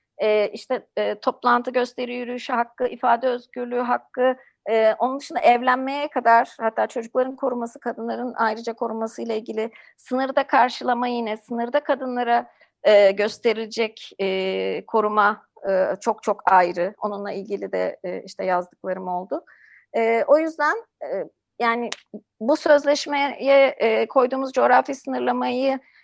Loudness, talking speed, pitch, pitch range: -22 LUFS, 125 wpm, 235 Hz, 215-260 Hz